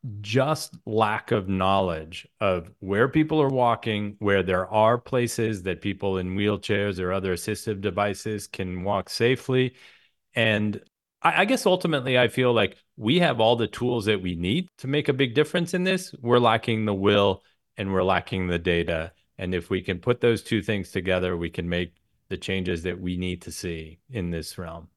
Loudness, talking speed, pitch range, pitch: -25 LUFS, 185 wpm, 95-120 Hz, 105 Hz